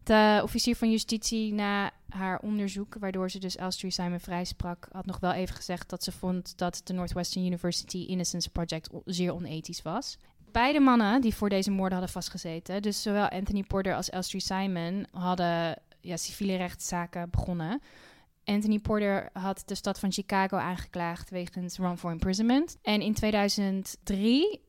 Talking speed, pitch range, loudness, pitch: 160 wpm, 180-205 Hz, -30 LUFS, 190 Hz